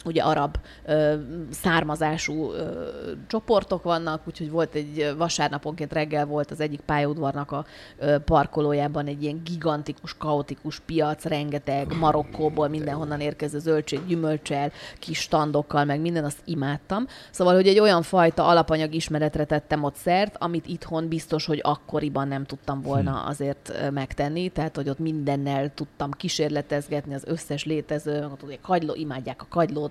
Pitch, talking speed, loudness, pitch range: 150 Hz, 140 wpm, -25 LUFS, 145-160 Hz